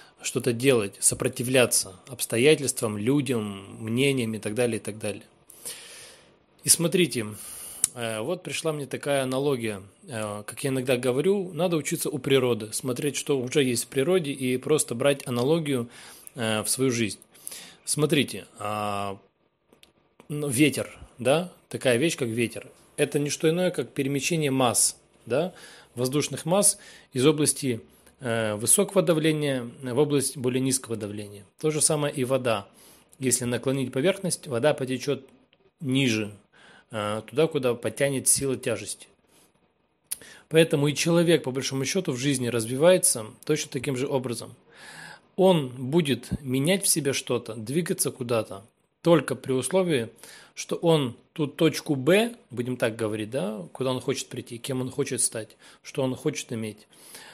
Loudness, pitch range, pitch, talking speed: -25 LUFS, 120-150 Hz, 130 Hz, 135 wpm